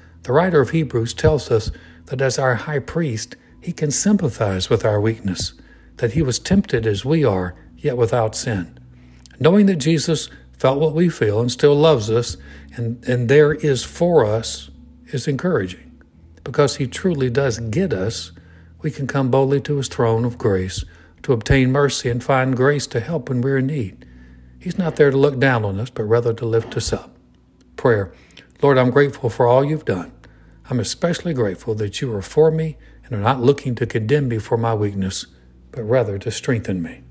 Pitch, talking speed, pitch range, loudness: 120 Hz, 190 wpm, 100-145 Hz, -19 LUFS